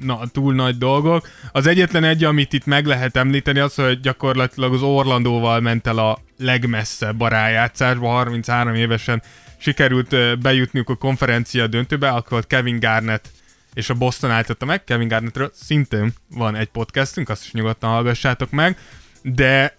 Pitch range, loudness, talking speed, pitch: 115-135 Hz, -18 LUFS, 155 wpm, 125 Hz